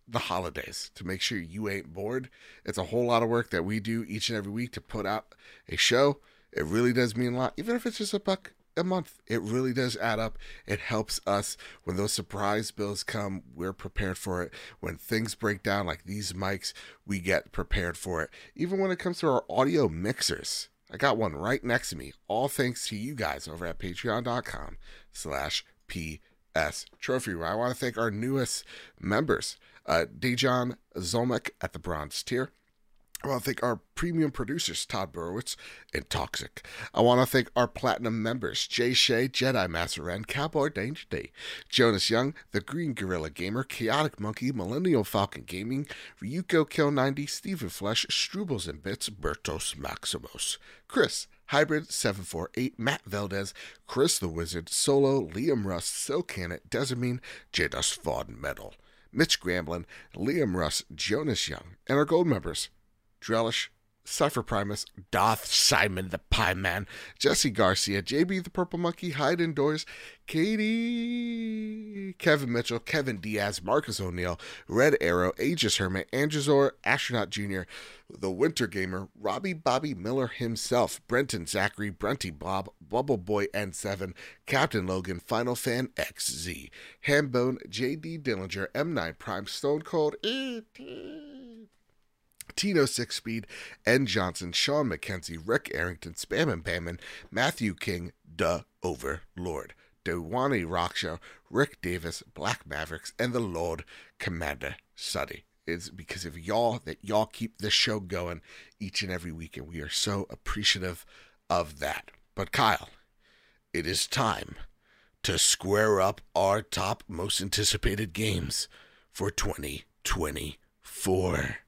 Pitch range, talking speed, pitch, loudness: 95-135 Hz, 150 wpm, 110 Hz, -29 LUFS